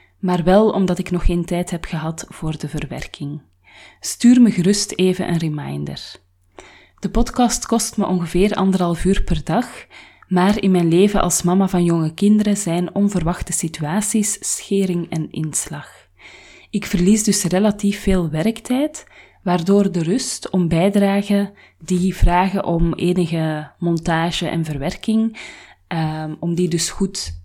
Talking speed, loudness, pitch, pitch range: 145 wpm, -19 LUFS, 180 Hz, 165-200 Hz